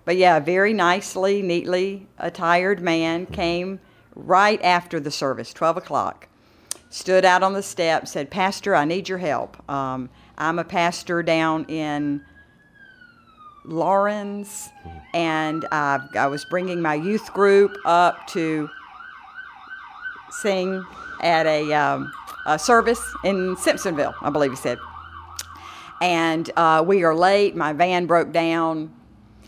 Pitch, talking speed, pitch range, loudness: 170 Hz, 130 wpm, 155-190 Hz, -21 LUFS